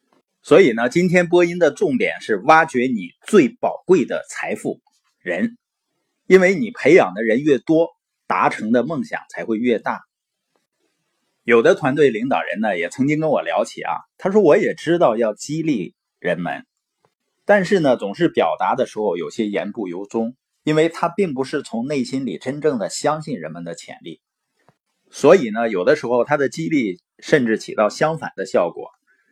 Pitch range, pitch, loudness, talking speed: 135-200 Hz, 160 Hz, -18 LUFS, 250 characters per minute